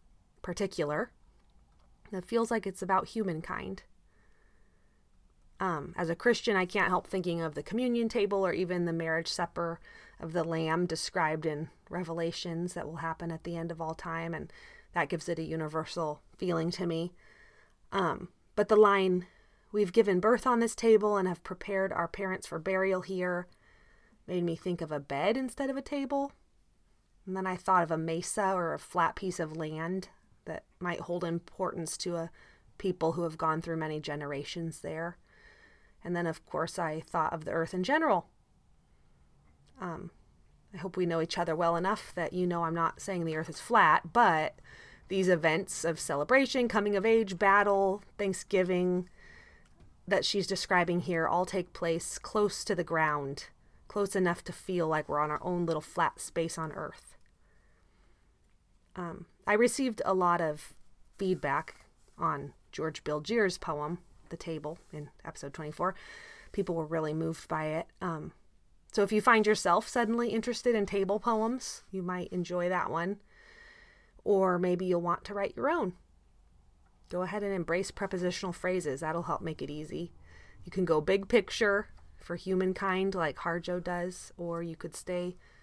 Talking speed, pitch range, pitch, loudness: 165 wpm, 165-195 Hz, 180 Hz, -31 LUFS